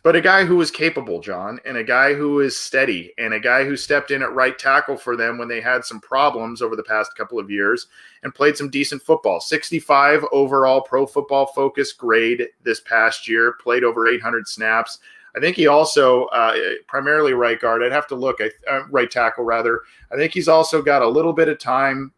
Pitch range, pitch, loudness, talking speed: 120-150 Hz, 135 Hz, -18 LUFS, 215 wpm